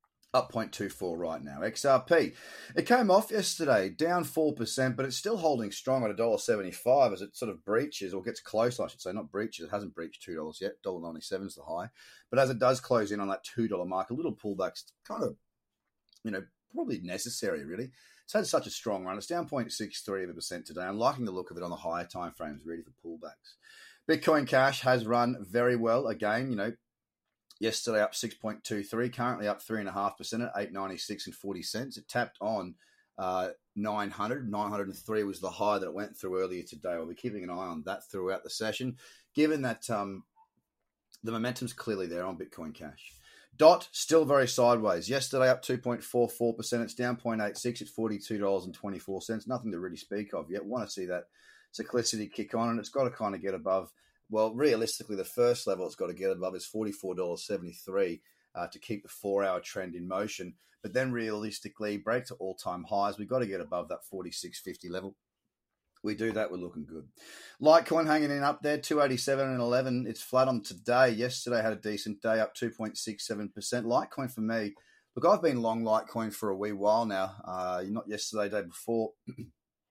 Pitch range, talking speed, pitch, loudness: 100-130 Hz, 210 wpm, 115 Hz, -32 LUFS